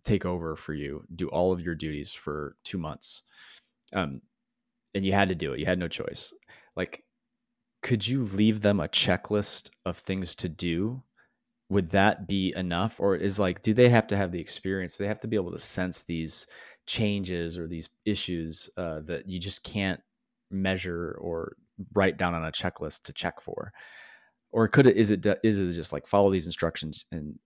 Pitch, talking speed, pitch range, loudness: 95 Hz, 195 wpm, 85-110 Hz, -28 LUFS